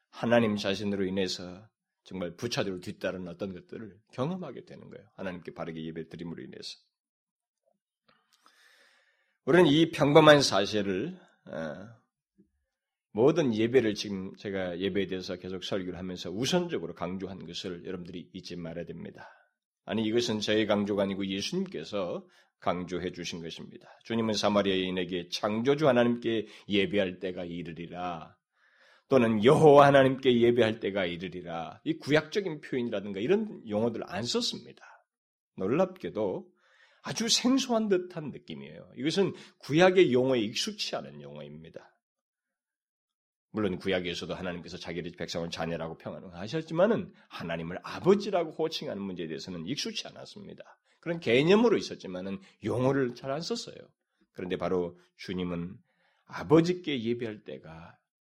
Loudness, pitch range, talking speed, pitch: -29 LUFS, 90-145 Hz, 335 characters per minute, 105 Hz